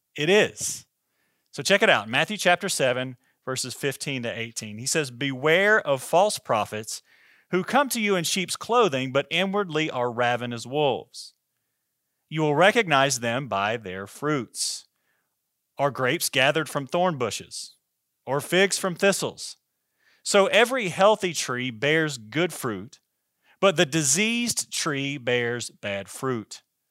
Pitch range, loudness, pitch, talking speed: 125-185 Hz, -24 LUFS, 145 Hz, 140 wpm